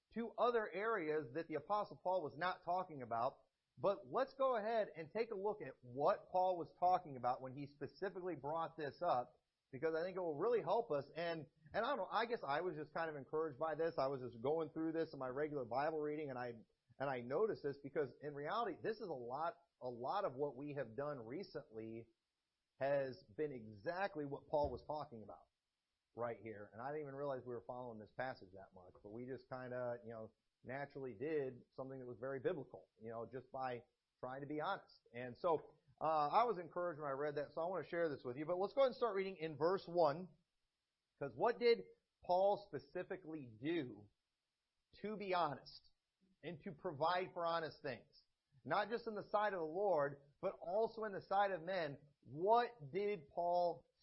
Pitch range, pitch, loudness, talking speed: 135-185 Hz, 155 Hz, -43 LUFS, 210 wpm